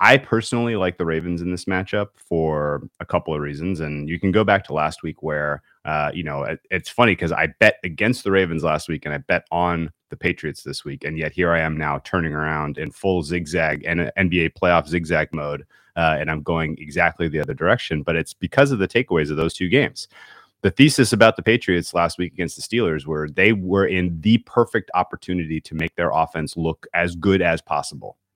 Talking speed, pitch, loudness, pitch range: 220 wpm, 85 Hz, -21 LUFS, 80-95 Hz